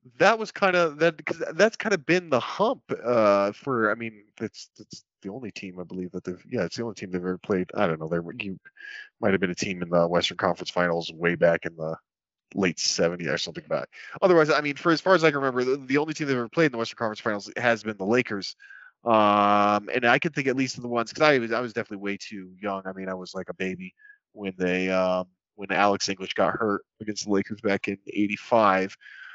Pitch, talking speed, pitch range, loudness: 105 Hz, 250 wpm, 95-135 Hz, -25 LUFS